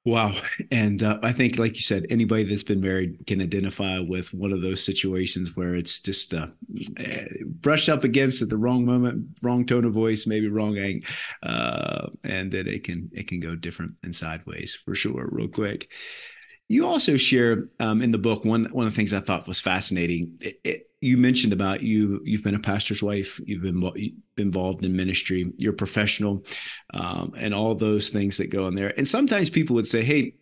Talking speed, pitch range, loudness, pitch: 205 wpm, 95-115 Hz, -24 LUFS, 105 Hz